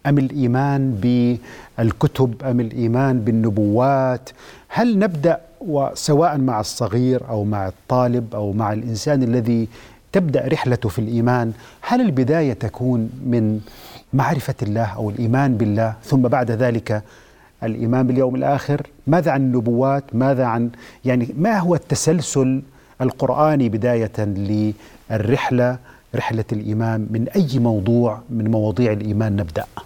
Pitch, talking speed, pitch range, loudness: 125 Hz, 115 wpm, 115-135 Hz, -19 LUFS